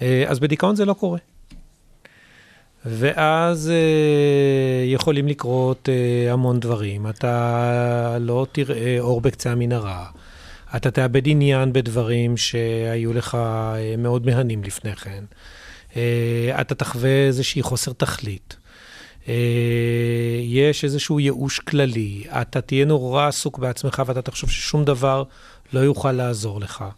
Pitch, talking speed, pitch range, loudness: 125 Hz, 115 wpm, 120-140 Hz, -20 LUFS